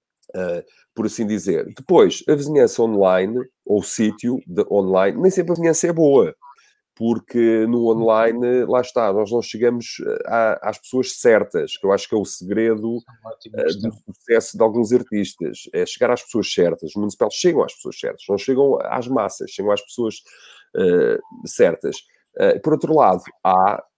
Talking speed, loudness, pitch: 170 wpm, -19 LUFS, 130 Hz